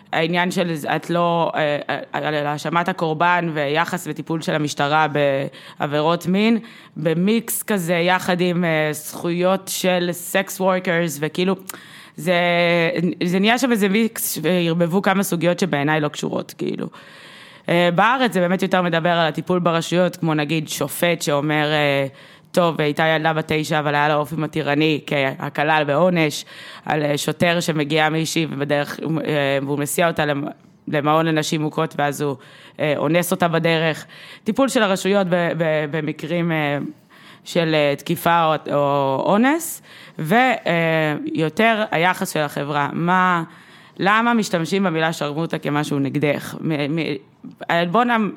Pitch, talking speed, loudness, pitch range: 165 Hz, 120 wpm, -19 LUFS, 150-180 Hz